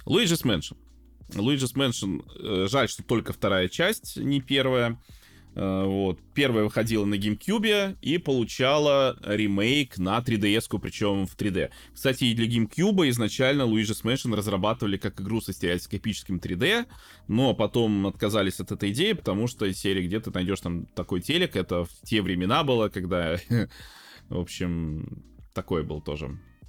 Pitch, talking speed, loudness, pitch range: 105 Hz, 140 wpm, -26 LUFS, 95-120 Hz